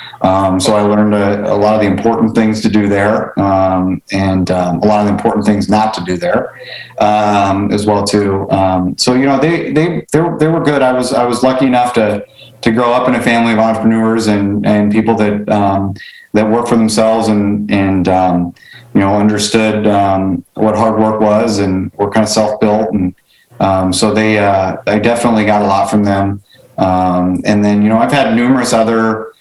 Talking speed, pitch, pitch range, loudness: 210 wpm, 105 Hz, 100-115 Hz, -12 LUFS